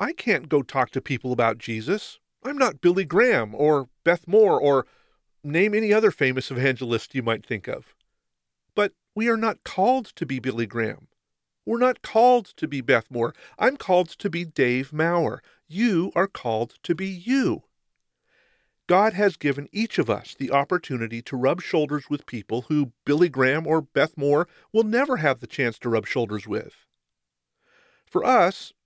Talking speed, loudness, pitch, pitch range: 175 wpm, -23 LUFS, 145 Hz, 125-195 Hz